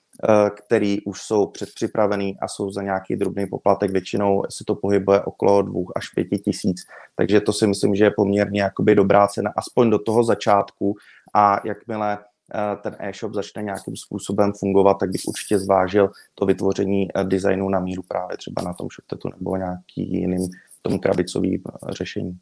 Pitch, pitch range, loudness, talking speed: 100 Hz, 95-105 Hz, -21 LUFS, 165 wpm